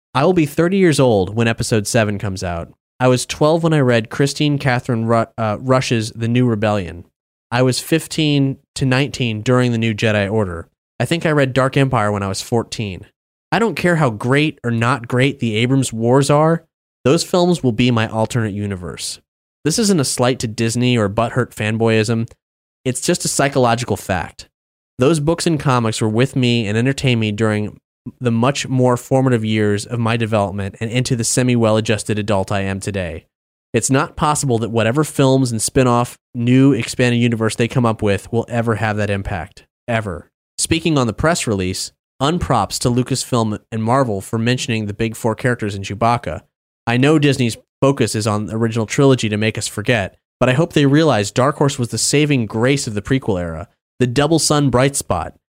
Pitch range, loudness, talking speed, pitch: 110-135 Hz, -17 LUFS, 190 wpm, 120 Hz